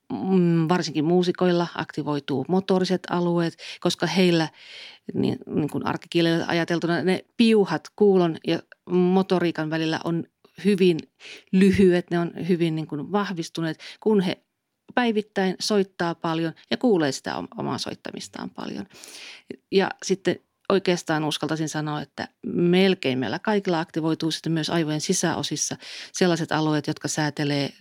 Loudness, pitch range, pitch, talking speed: -24 LUFS, 160-185 Hz, 170 Hz, 120 wpm